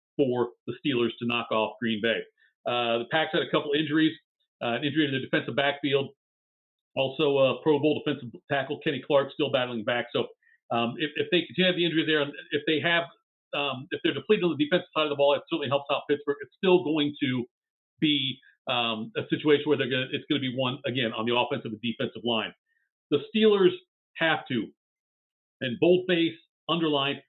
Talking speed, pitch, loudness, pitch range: 200 wpm, 145 Hz, -27 LUFS, 125-160 Hz